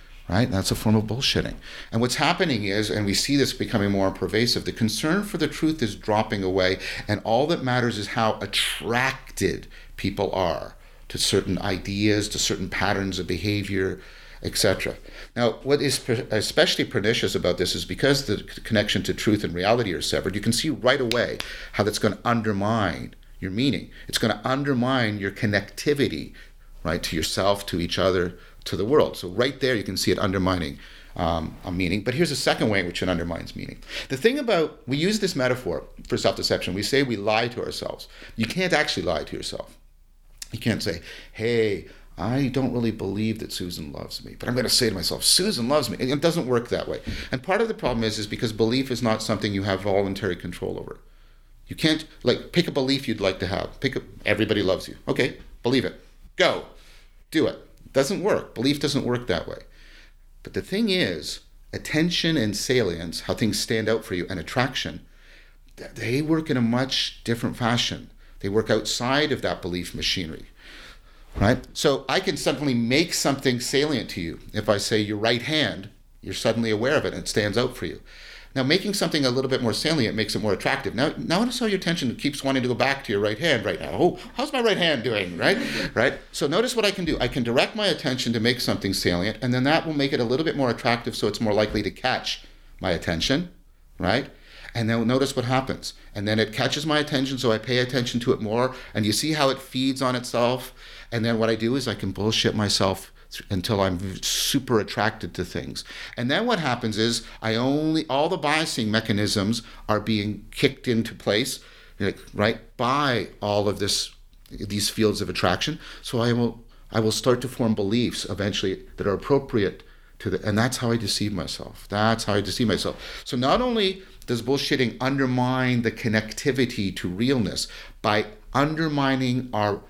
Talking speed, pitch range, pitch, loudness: 200 wpm, 100-135 Hz, 115 Hz, -24 LUFS